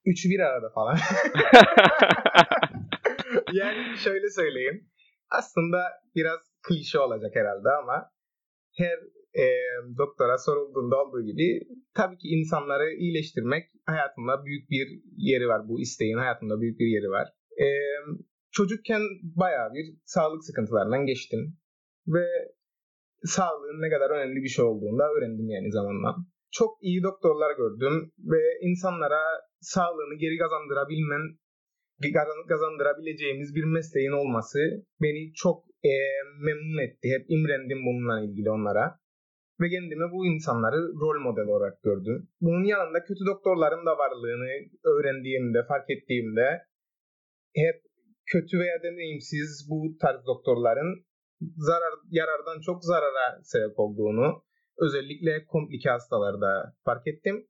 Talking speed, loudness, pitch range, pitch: 115 wpm, -26 LUFS, 140-185 Hz, 160 Hz